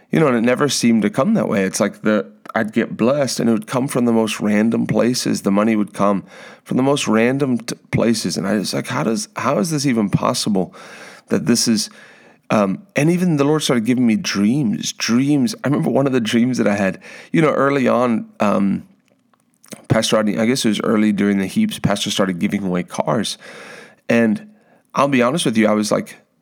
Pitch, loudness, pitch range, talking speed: 120 Hz, -18 LUFS, 105-160 Hz, 220 wpm